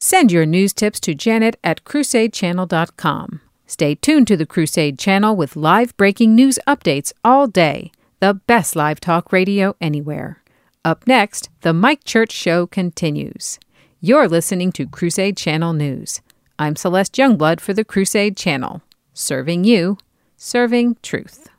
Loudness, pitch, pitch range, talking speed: -16 LUFS, 190 Hz, 165-225 Hz, 140 wpm